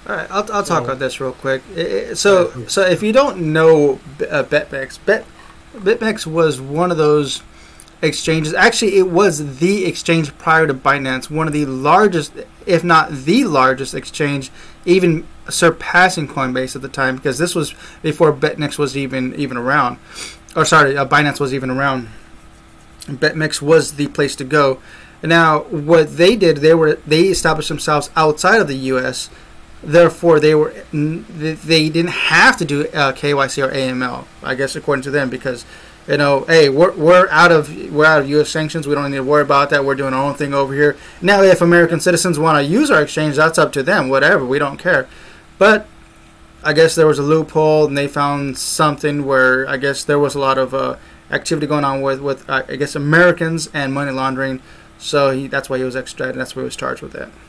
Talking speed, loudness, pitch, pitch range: 200 wpm, -15 LUFS, 150 Hz, 135-165 Hz